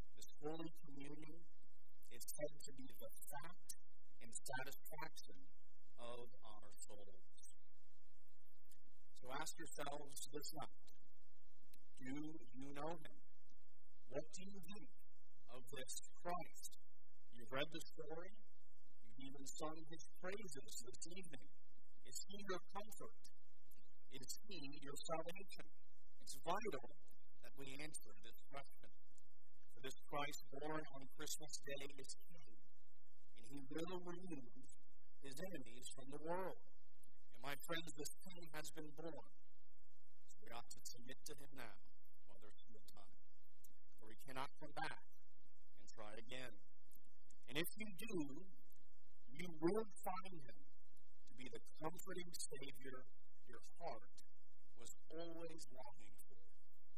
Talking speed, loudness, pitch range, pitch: 125 wpm, -53 LUFS, 125-165 Hz, 140 Hz